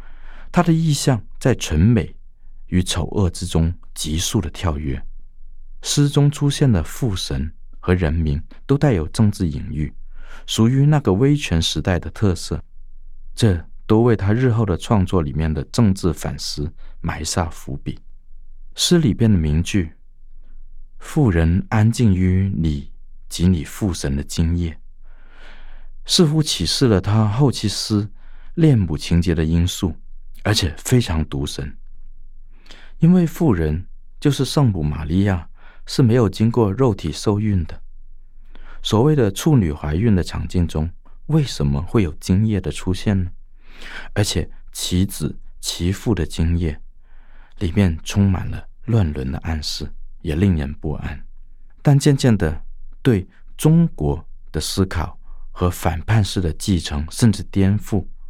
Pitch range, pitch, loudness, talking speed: 80-115 Hz, 95 Hz, -19 LUFS, 200 characters per minute